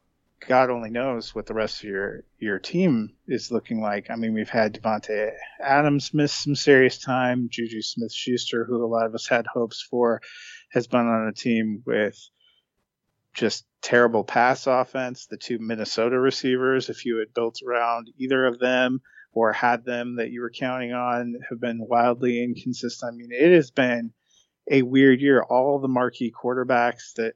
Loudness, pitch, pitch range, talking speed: -23 LUFS, 120 Hz, 115-130 Hz, 180 wpm